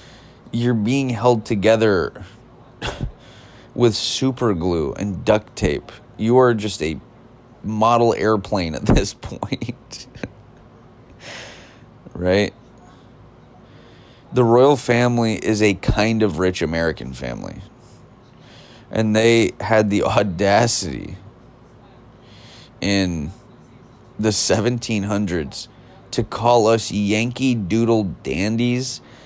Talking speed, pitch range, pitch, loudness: 90 wpm, 100-120 Hz, 110 Hz, -19 LUFS